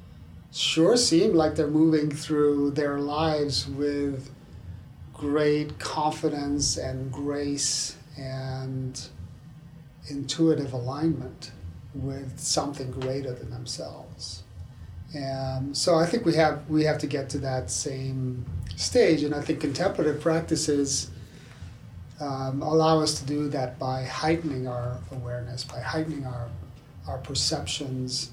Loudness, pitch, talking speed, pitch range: -26 LUFS, 140 Hz, 115 wpm, 125-150 Hz